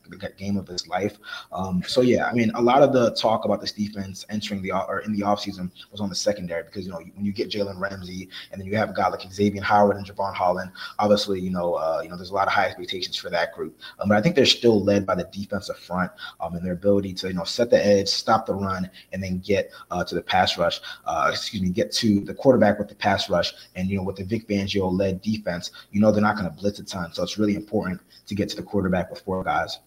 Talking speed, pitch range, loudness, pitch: 275 wpm, 95-105 Hz, -24 LUFS, 100 Hz